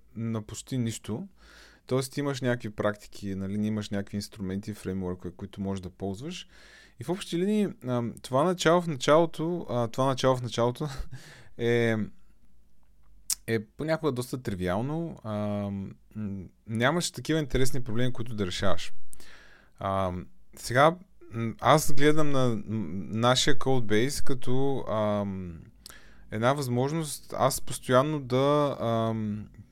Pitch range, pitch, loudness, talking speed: 105-140 Hz, 120 Hz, -29 LUFS, 105 wpm